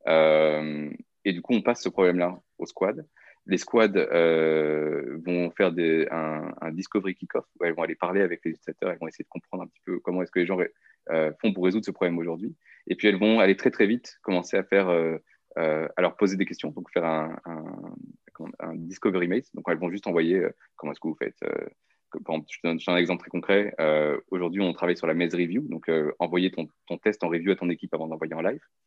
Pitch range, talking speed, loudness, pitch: 80-90 Hz, 245 wpm, -26 LUFS, 85 Hz